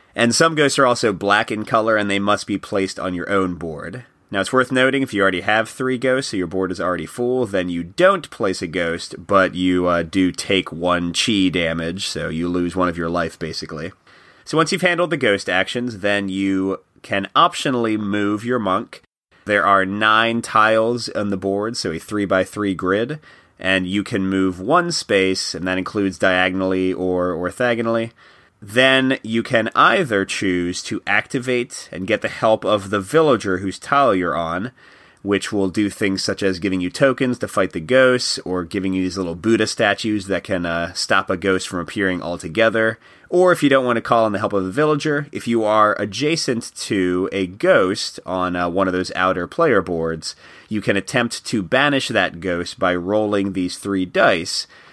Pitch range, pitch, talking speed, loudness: 90-115 Hz, 100 Hz, 200 wpm, -19 LUFS